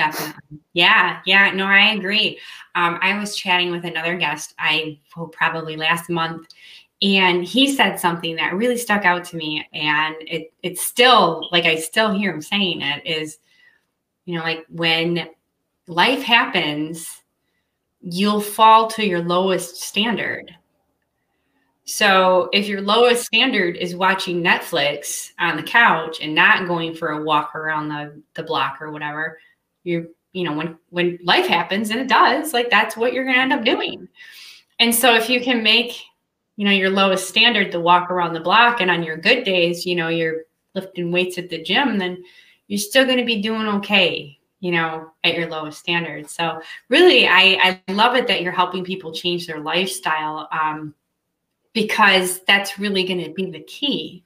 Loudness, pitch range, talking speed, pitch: -18 LUFS, 165-205 Hz, 175 wpm, 180 Hz